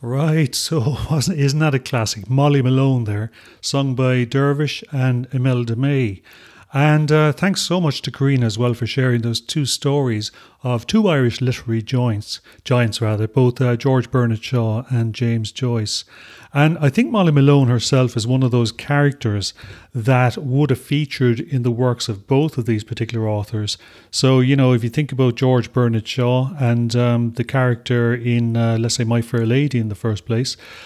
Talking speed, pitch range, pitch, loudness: 185 wpm, 115-140 Hz, 125 Hz, -18 LUFS